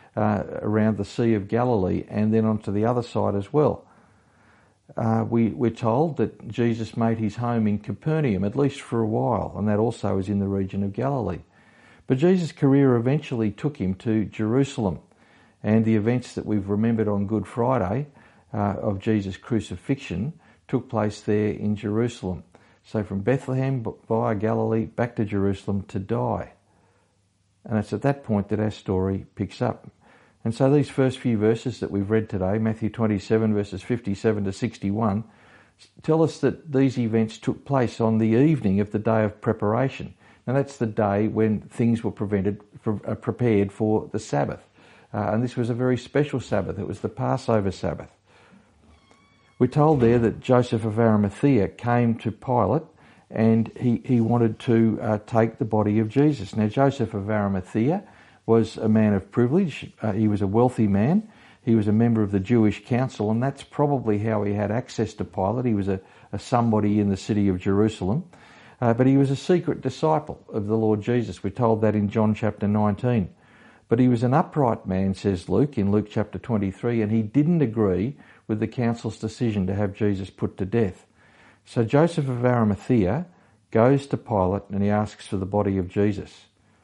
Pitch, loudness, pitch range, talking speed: 110 Hz, -24 LUFS, 105-120 Hz, 185 wpm